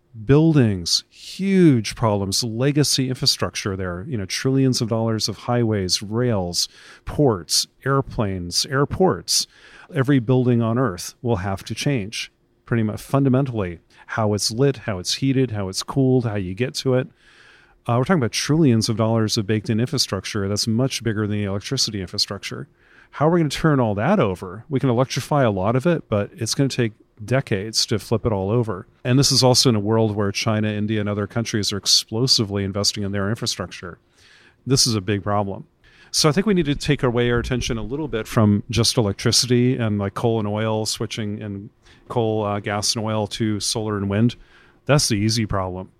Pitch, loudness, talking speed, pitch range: 115 Hz, -20 LUFS, 190 wpm, 105-130 Hz